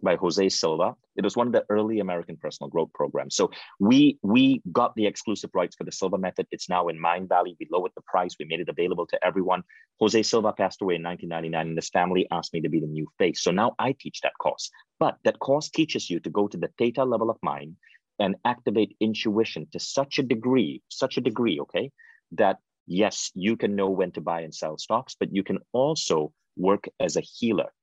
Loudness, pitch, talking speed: -26 LUFS, 110 Hz, 225 wpm